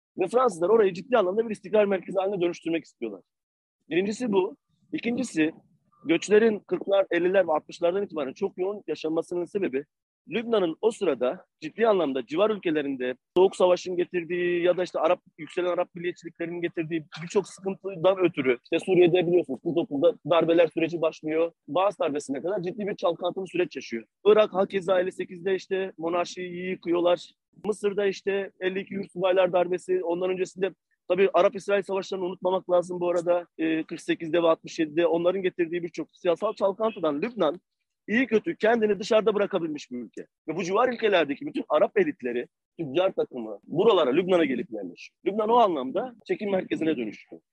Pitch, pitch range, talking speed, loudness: 180 Hz, 170-200 Hz, 150 wpm, -26 LUFS